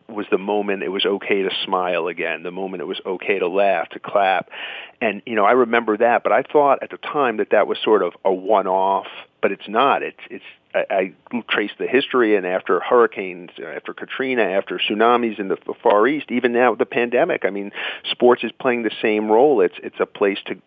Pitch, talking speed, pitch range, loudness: 110 Hz, 220 wpm, 100-125 Hz, -19 LUFS